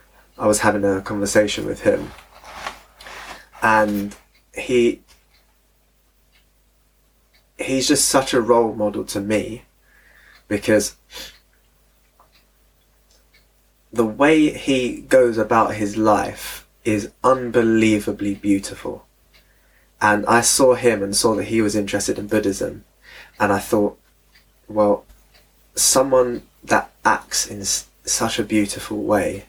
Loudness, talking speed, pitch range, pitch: -19 LUFS, 105 wpm, 105-120 Hz, 110 Hz